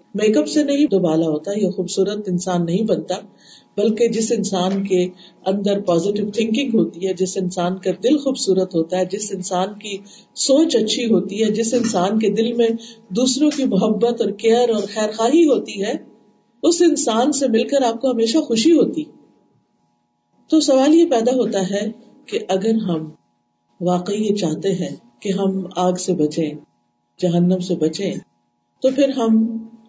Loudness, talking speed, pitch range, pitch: -19 LUFS, 170 wpm, 185-235 Hz, 205 Hz